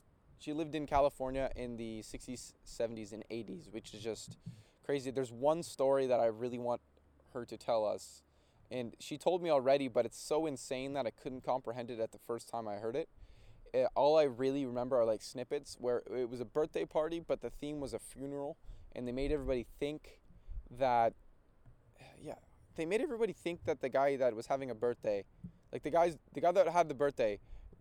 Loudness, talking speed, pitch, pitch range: -36 LUFS, 205 wpm, 125 Hz, 115-145 Hz